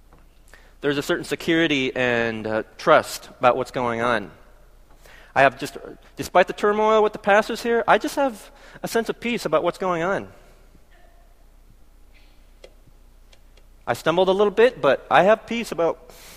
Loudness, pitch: -21 LUFS, 150 Hz